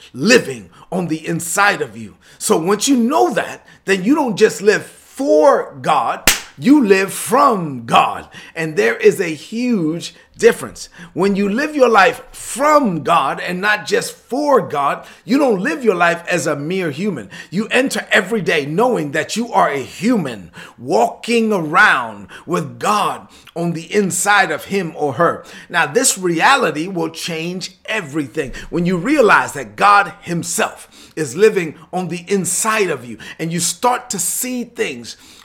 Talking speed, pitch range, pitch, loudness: 160 wpm, 165-225 Hz, 195 Hz, -16 LUFS